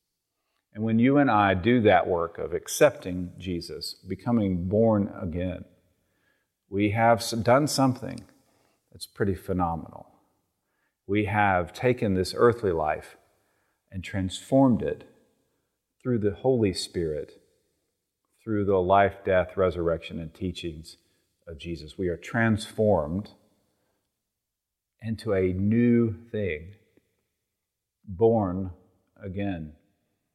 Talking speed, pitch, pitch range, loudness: 105 wpm, 100 Hz, 90-115 Hz, -26 LUFS